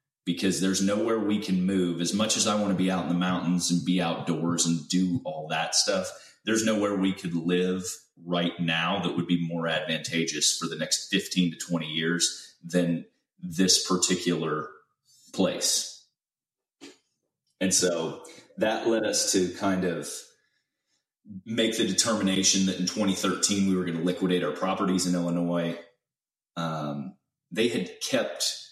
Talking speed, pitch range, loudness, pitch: 155 wpm, 85-95 Hz, -26 LUFS, 90 Hz